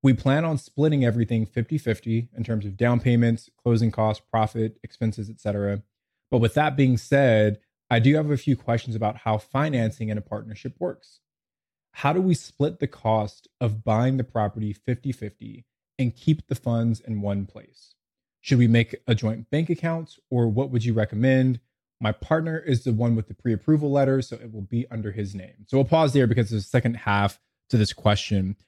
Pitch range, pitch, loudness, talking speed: 110-130 Hz, 115 Hz, -24 LUFS, 195 wpm